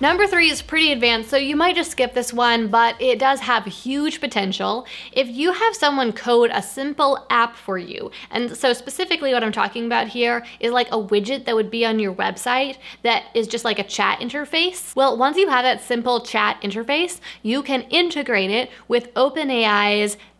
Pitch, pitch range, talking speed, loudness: 245 Hz, 230-280 Hz, 195 wpm, -20 LUFS